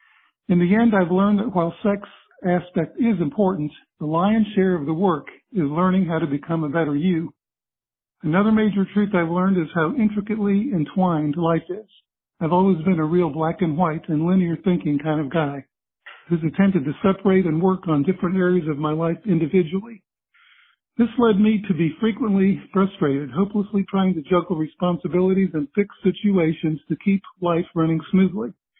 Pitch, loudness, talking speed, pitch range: 180 Hz, -21 LUFS, 175 wpm, 160-200 Hz